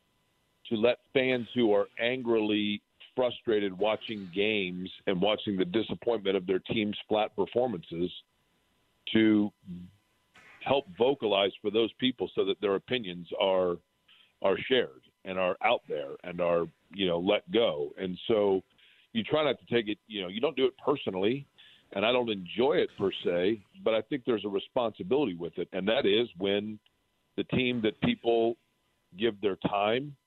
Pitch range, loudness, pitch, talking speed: 95-120 Hz, -30 LUFS, 105 Hz, 165 wpm